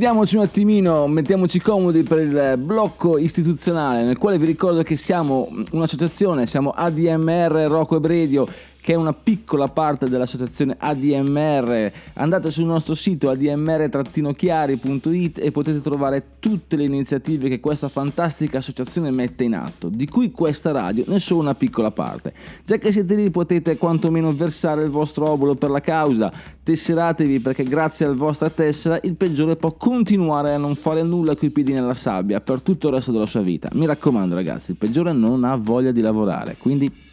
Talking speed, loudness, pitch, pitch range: 170 wpm, -20 LUFS, 155 Hz, 140-170 Hz